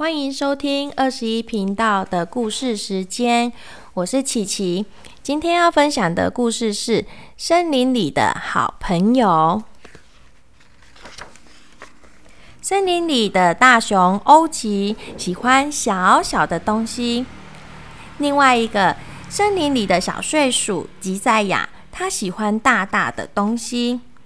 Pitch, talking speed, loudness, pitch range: 235 Hz, 175 characters per minute, -18 LUFS, 205-270 Hz